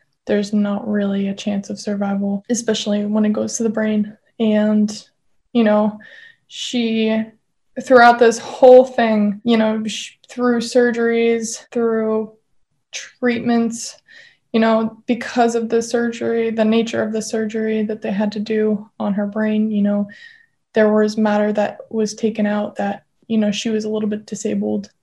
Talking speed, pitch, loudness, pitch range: 160 wpm, 220 Hz, -18 LUFS, 210-230 Hz